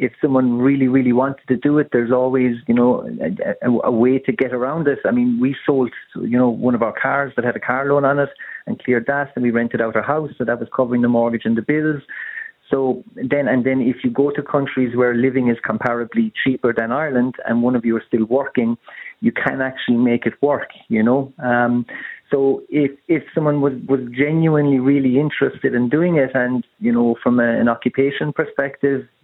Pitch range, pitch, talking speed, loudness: 120-140 Hz, 130 Hz, 220 wpm, -18 LUFS